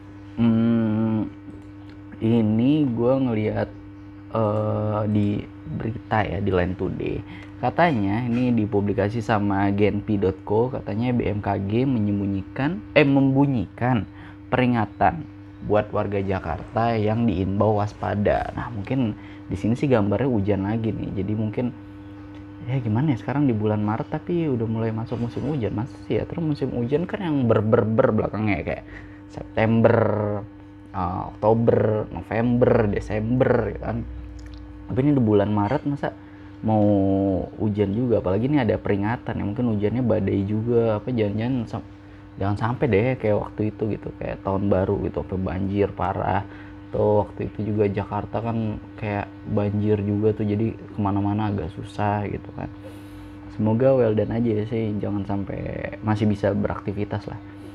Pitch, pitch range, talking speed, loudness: 105 Hz, 100-115 Hz, 135 wpm, -23 LUFS